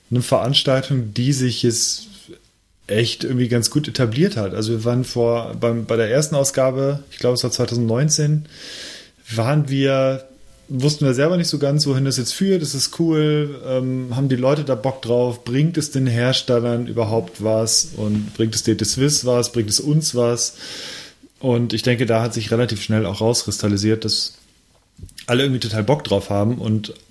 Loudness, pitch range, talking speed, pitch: -19 LUFS, 115-135 Hz, 180 wpm, 125 Hz